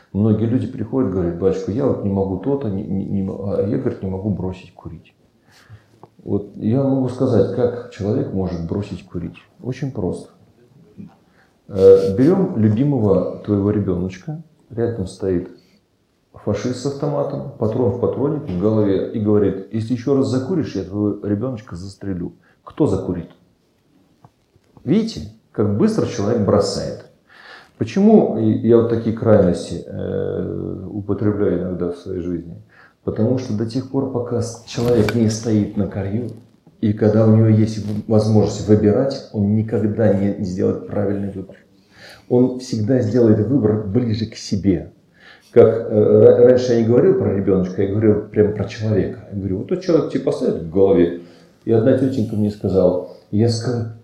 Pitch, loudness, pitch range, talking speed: 105 Hz, -18 LUFS, 95-120 Hz, 150 wpm